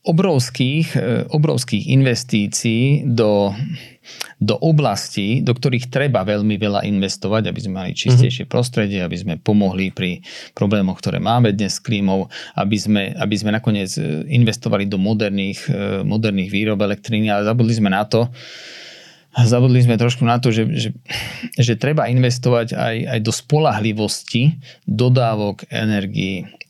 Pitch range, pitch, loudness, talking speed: 105-125 Hz, 115 Hz, -18 LUFS, 135 wpm